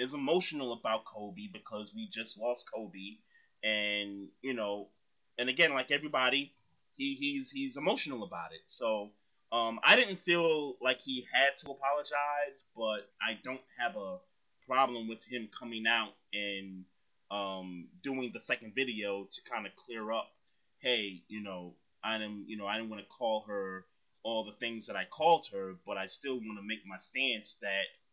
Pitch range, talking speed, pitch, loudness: 100-135 Hz, 175 wpm, 115 Hz, -34 LUFS